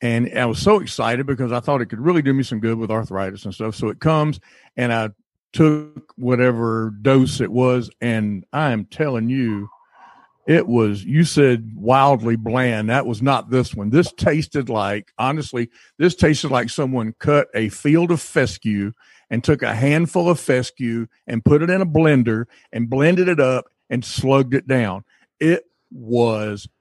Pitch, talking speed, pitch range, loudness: 125 Hz, 180 wpm, 115-145 Hz, -19 LUFS